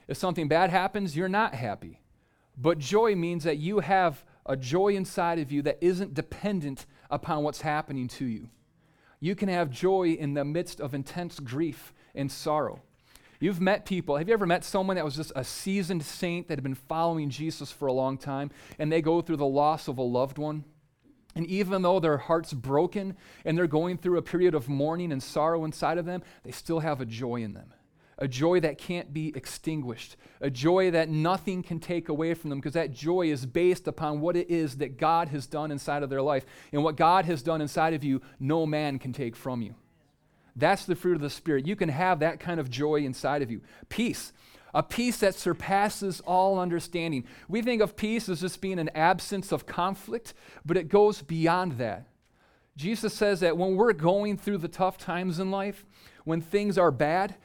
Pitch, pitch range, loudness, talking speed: 165 Hz, 145-185 Hz, -28 LUFS, 205 wpm